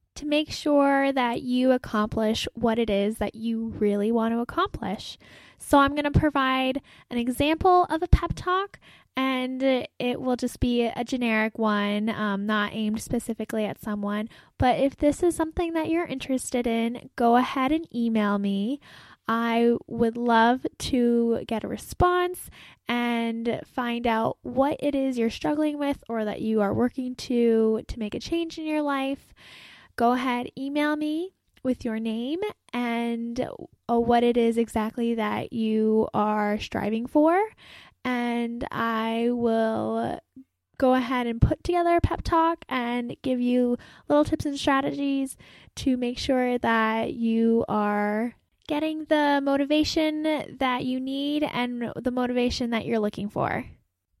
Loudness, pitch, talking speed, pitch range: -25 LUFS, 245 Hz, 150 wpm, 225-280 Hz